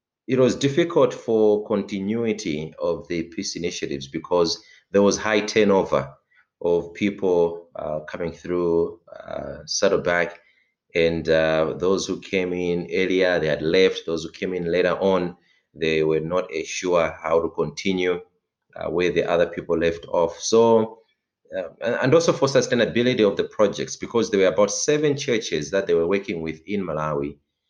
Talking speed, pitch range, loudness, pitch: 160 wpm, 85-105 Hz, -22 LUFS, 90 Hz